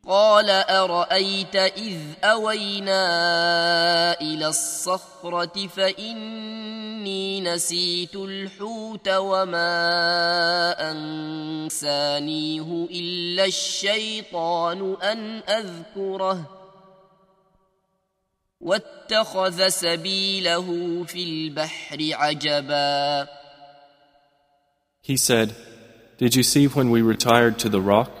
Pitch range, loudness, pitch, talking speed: 155-190 Hz, -22 LUFS, 175 Hz, 50 wpm